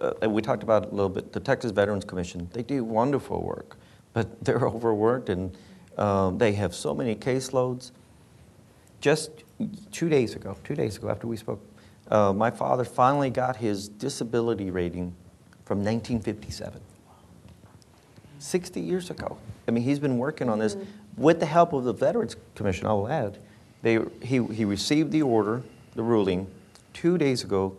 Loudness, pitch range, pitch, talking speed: -27 LUFS, 100-130 Hz, 110 Hz, 165 wpm